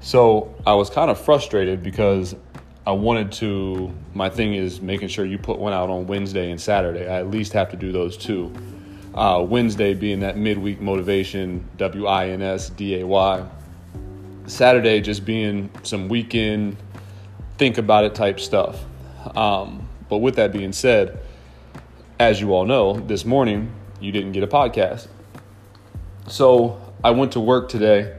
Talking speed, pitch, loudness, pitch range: 165 wpm, 100 Hz, -20 LUFS, 95-105 Hz